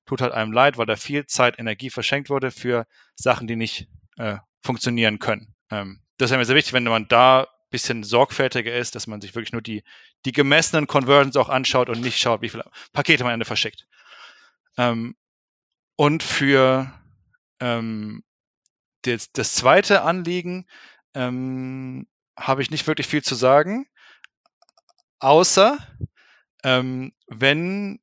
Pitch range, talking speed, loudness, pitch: 115-145 Hz, 150 wpm, -20 LUFS, 130 Hz